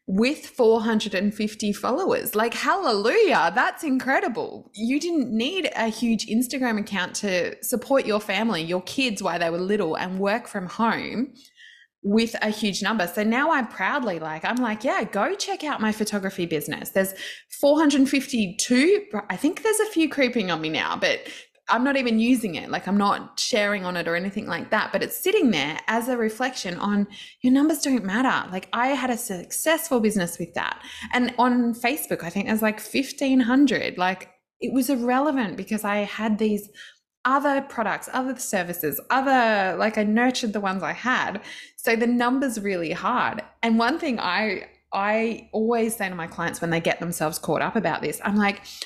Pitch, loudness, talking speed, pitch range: 225 Hz, -24 LUFS, 180 wpm, 200-260 Hz